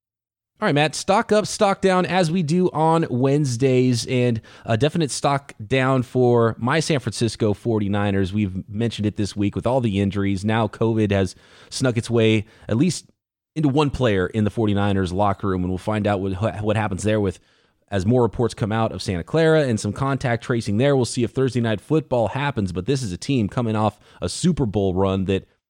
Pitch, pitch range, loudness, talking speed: 115 Hz, 105-135 Hz, -21 LUFS, 205 wpm